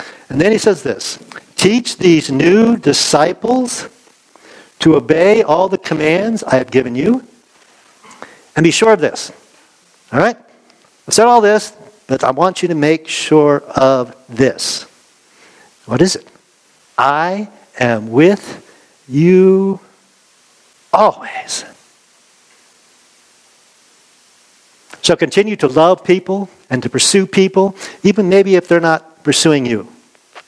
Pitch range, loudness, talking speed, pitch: 145-205 Hz, -13 LUFS, 120 wpm, 180 Hz